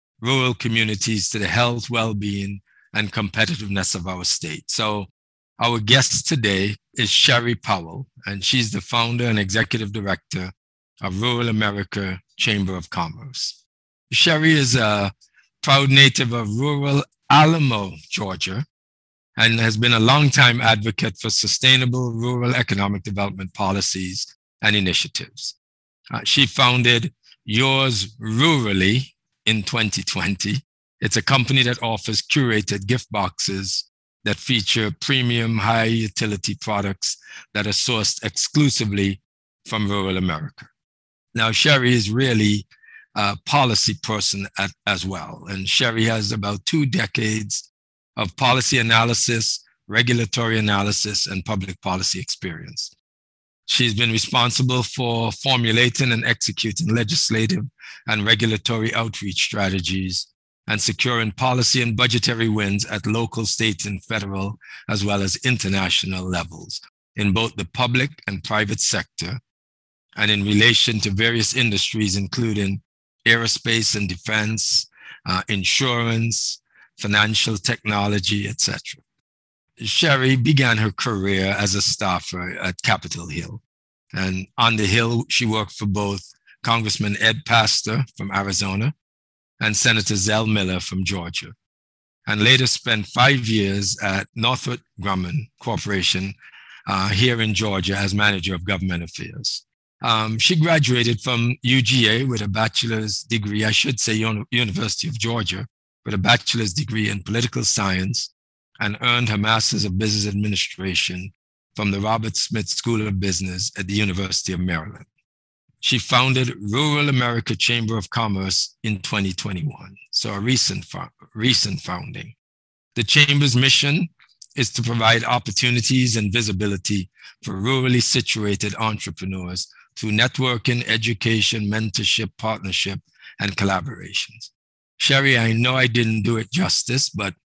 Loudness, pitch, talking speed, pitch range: -19 LUFS, 110 Hz, 125 wpm, 100-120 Hz